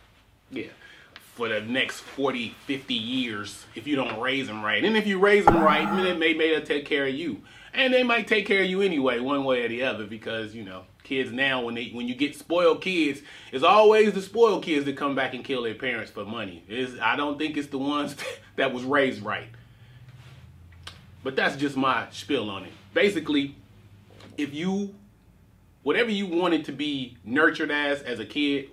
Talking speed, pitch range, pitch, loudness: 205 wpm, 115-160 Hz, 140 Hz, -25 LUFS